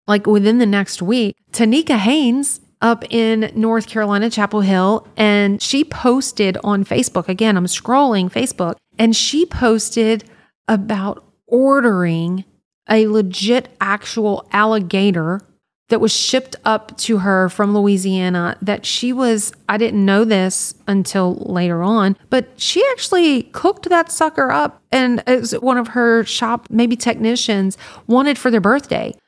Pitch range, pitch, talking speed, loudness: 200-245 Hz, 220 Hz, 140 wpm, -16 LUFS